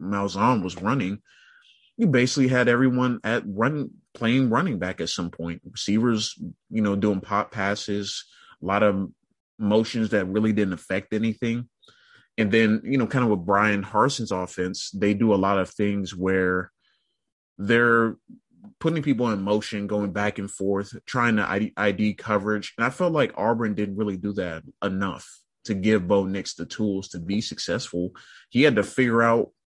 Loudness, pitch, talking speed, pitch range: -24 LUFS, 105 Hz, 170 wpm, 100-115 Hz